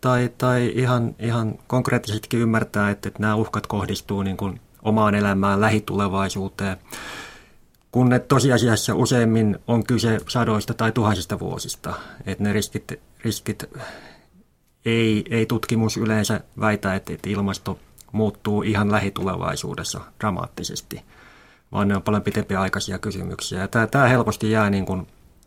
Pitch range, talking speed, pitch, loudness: 100-115 Hz, 130 wpm, 110 Hz, -22 LUFS